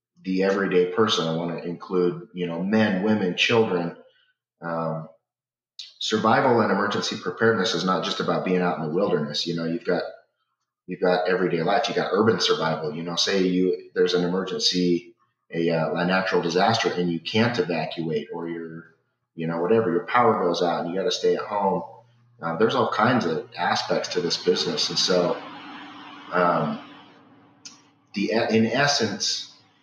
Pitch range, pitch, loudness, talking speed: 85-100 Hz, 90 Hz, -23 LUFS, 170 wpm